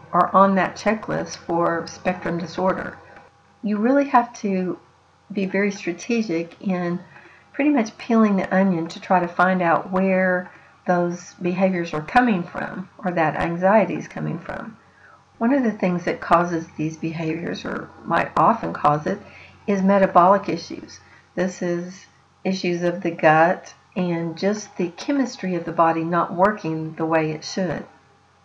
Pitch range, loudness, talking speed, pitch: 170-195 Hz, -21 LUFS, 150 wpm, 180 Hz